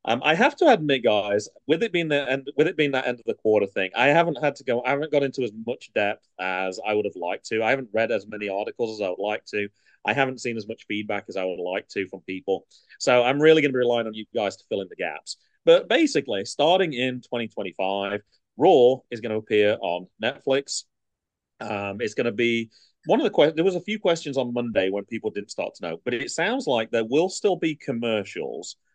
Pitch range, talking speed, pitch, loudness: 105-140 Hz, 245 wpm, 120 Hz, -24 LUFS